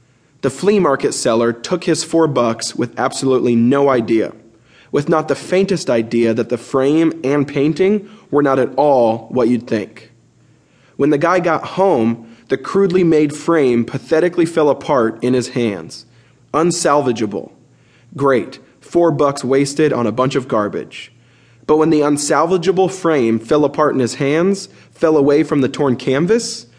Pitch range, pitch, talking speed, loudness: 120-160 Hz, 140 Hz, 155 wpm, -16 LUFS